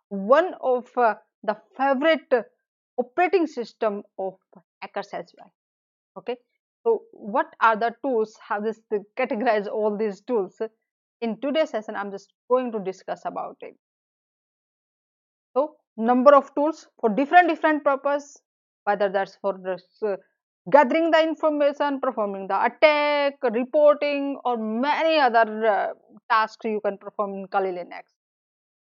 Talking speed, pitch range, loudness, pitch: 135 wpm, 210-290 Hz, -23 LUFS, 235 Hz